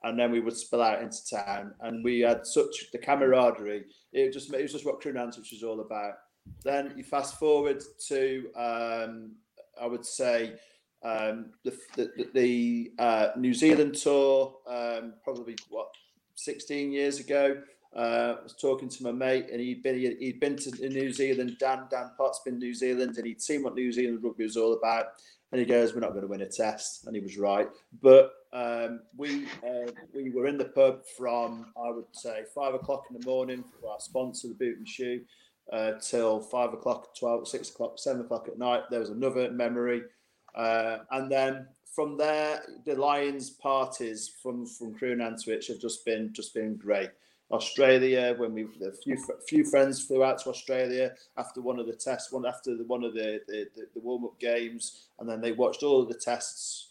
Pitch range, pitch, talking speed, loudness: 115-135 Hz, 125 Hz, 195 wpm, -30 LUFS